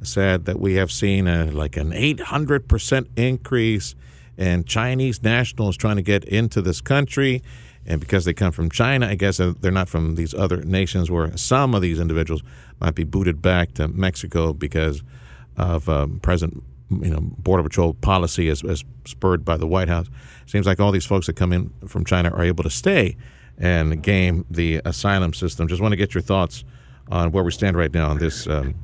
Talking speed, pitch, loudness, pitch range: 200 wpm, 90 Hz, -21 LUFS, 80-100 Hz